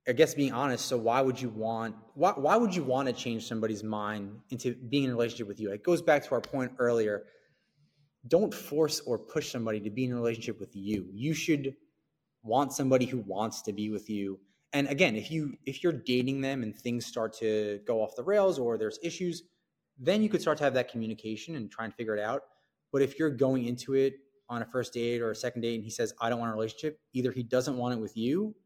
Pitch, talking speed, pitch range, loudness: 125 Hz, 245 wpm, 110-145 Hz, -31 LUFS